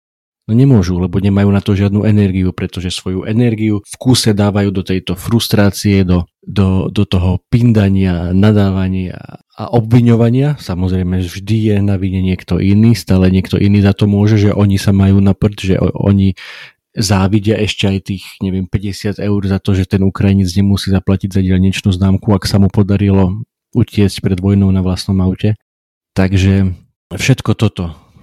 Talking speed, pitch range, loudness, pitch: 160 wpm, 95-105 Hz, -13 LUFS, 100 Hz